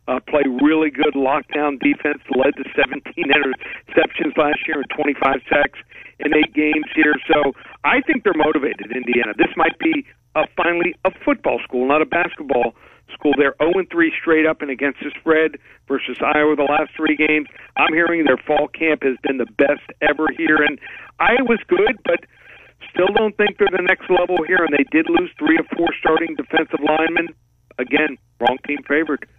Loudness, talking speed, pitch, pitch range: -18 LUFS, 180 wpm, 155 Hz, 145-170 Hz